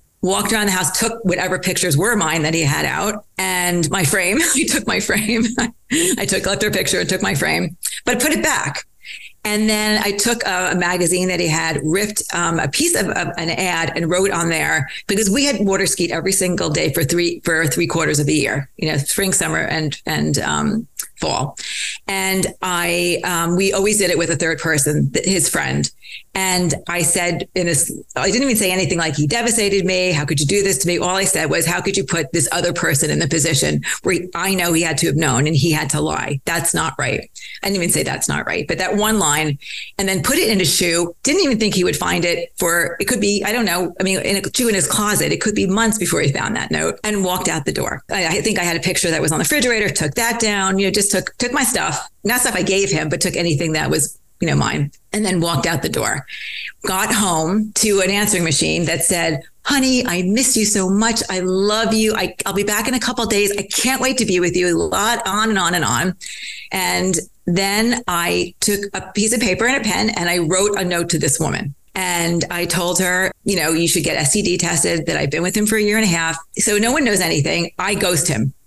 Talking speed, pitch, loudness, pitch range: 250 wpm, 185 Hz, -17 LUFS, 165-210 Hz